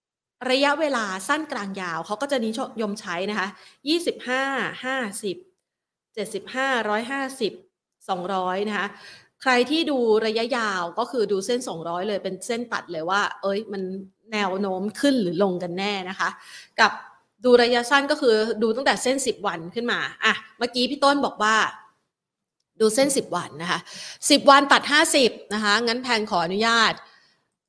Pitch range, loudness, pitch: 195-260 Hz, -23 LUFS, 220 Hz